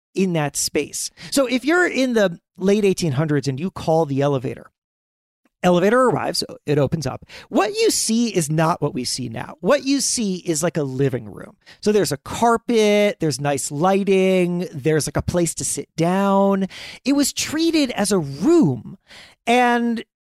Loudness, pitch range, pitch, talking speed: -20 LUFS, 150-230 Hz, 185 Hz, 170 wpm